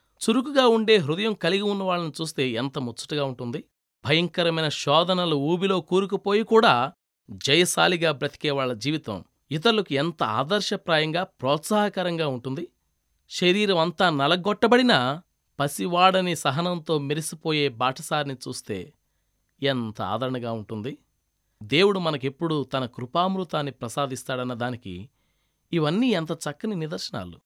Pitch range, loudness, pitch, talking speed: 130-180 Hz, -24 LUFS, 155 Hz, 95 wpm